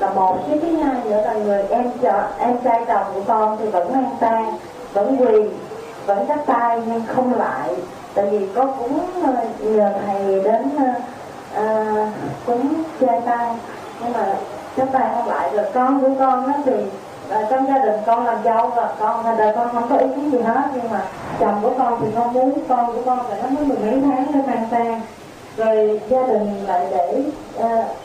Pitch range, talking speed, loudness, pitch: 215-260 Hz, 200 wpm, -19 LUFS, 235 Hz